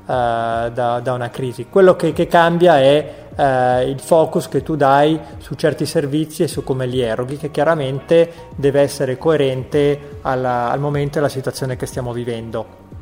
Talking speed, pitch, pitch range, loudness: 170 wpm, 140 Hz, 125-155 Hz, -17 LUFS